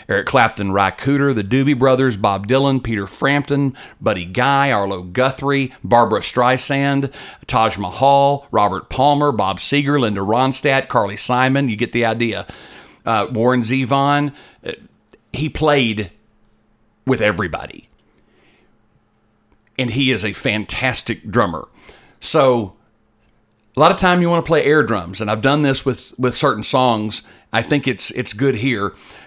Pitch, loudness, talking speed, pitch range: 125 Hz, -17 LUFS, 140 wpm, 110-140 Hz